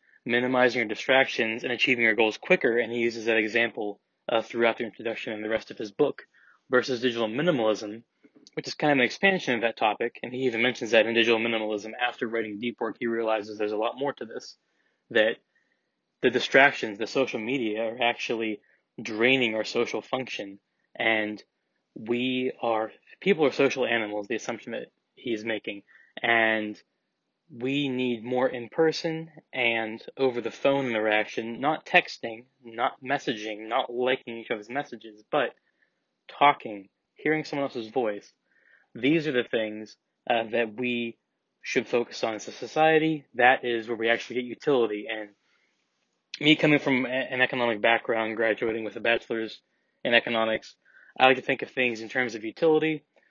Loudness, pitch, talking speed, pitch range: -26 LUFS, 120 Hz, 165 wpm, 110-130 Hz